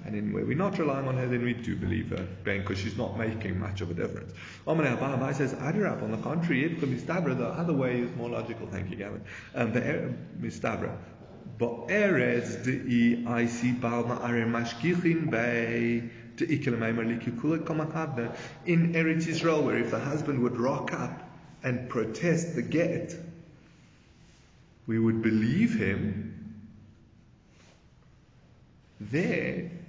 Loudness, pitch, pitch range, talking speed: -29 LUFS, 120 Hz, 115-155 Hz, 135 wpm